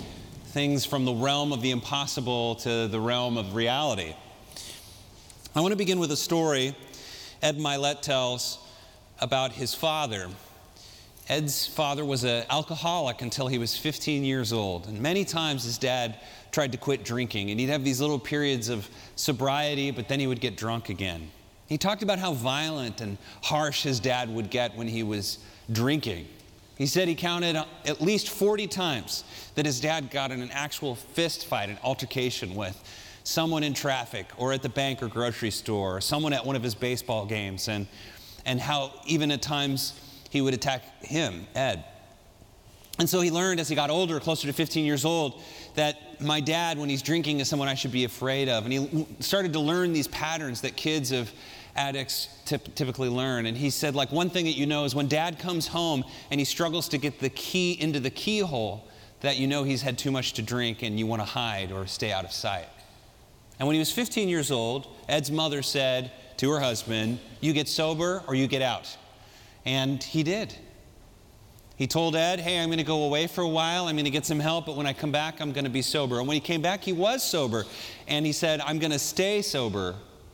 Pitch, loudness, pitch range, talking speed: 135 Hz, -28 LUFS, 115-155 Hz, 205 wpm